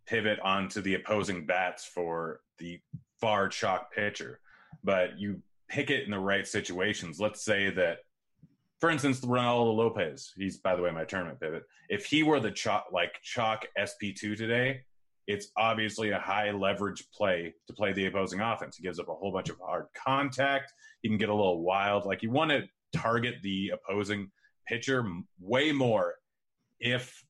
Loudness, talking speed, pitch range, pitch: -31 LUFS, 170 wpm, 95-120 Hz, 105 Hz